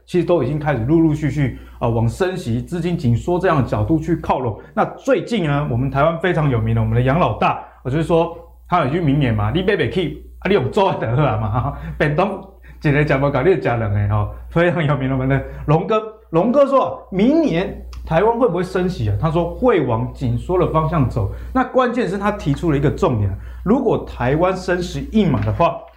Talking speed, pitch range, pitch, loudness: 320 characters per minute, 130-180 Hz, 160 Hz, -18 LUFS